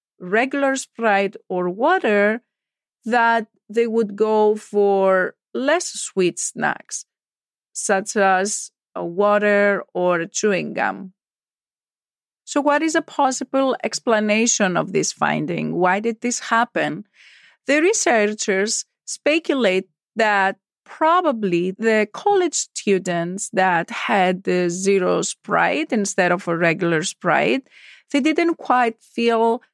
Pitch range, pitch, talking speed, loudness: 190-255 Hz, 215 Hz, 110 wpm, -20 LUFS